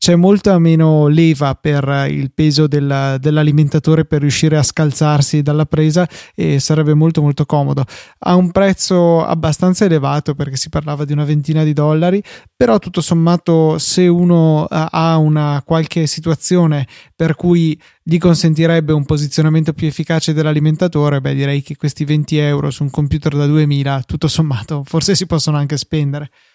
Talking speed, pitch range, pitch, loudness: 155 wpm, 145-165 Hz, 155 Hz, -14 LUFS